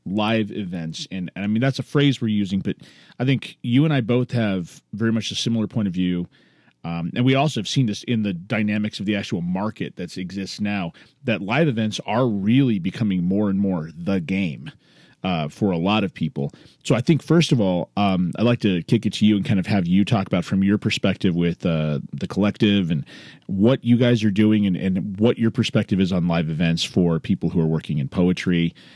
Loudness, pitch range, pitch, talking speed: -22 LUFS, 90-115 Hz, 100 Hz, 230 wpm